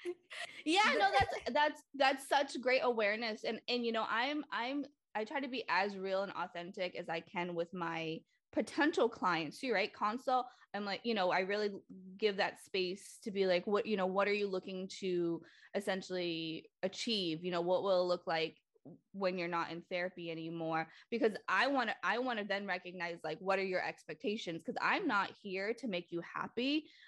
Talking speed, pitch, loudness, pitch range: 195 wpm, 195 Hz, -36 LUFS, 175-235 Hz